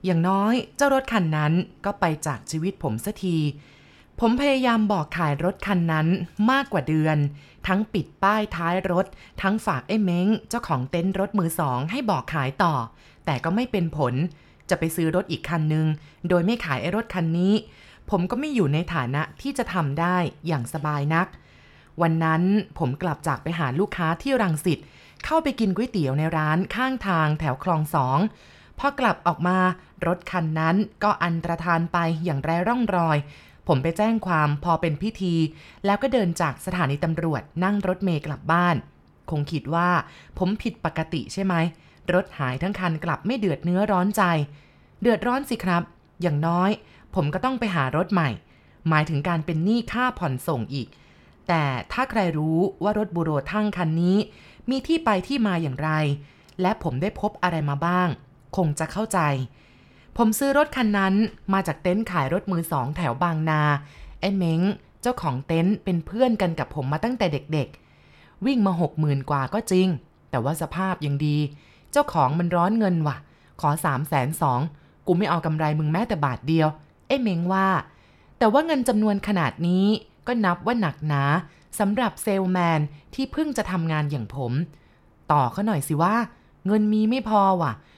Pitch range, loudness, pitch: 155-205 Hz, -24 LUFS, 175 Hz